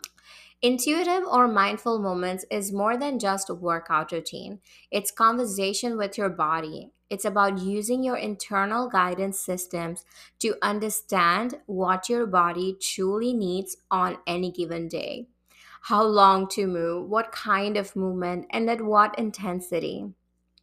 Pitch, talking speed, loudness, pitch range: 195 Hz, 135 wpm, -25 LUFS, 180-220 Hz